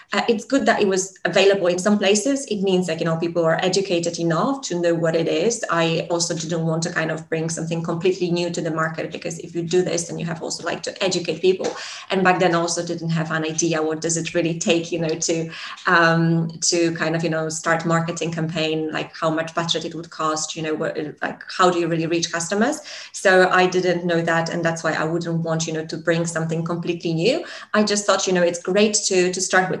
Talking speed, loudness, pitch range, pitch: 250 wpm, -21 LUFS, 165-185 Hz, 170 Hz